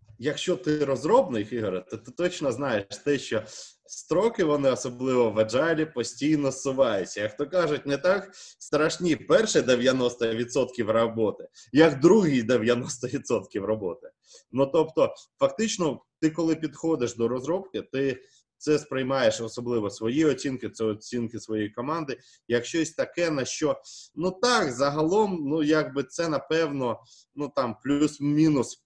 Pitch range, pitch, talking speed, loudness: 120-160 Hz, 140 Hz, 130 wpm, -26 LUFS